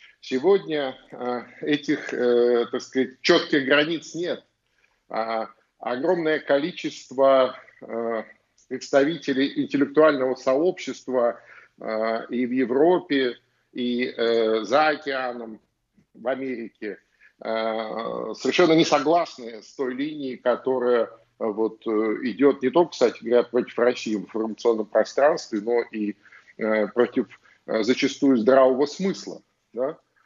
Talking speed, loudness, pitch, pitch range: 85 wpm, -23 LUFS, 130 Hz, 115-145 Hz